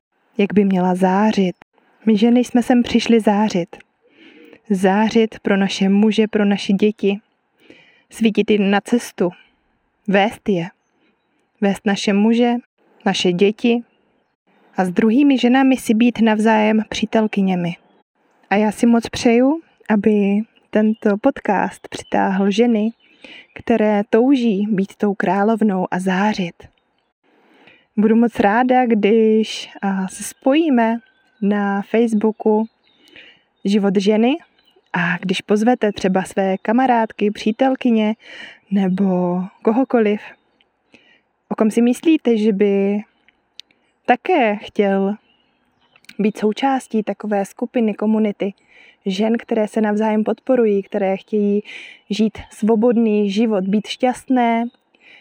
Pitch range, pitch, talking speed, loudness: 200-235 Hz, 215 Hz, 105 wpm, -17 LUFS